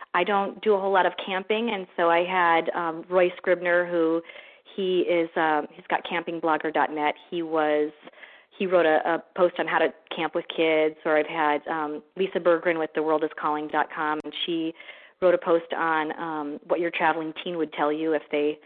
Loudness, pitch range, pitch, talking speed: -25 LUFS, 155-175 Hz, 165 Hz, 195 wpm